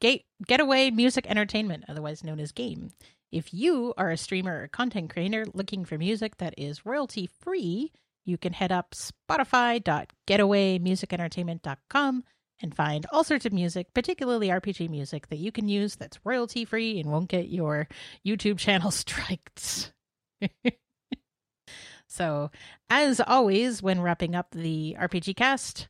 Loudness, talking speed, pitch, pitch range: -28 LUFS, 135 wpm, 195 Hz, 170-240 Hz